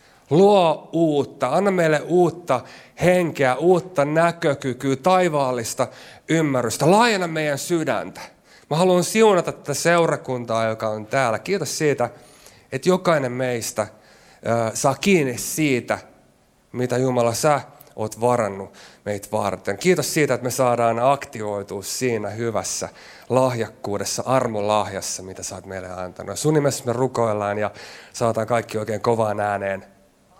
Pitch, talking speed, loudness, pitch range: 125 Hz, 120 wpm, -21 LUFS, 110-150 Hz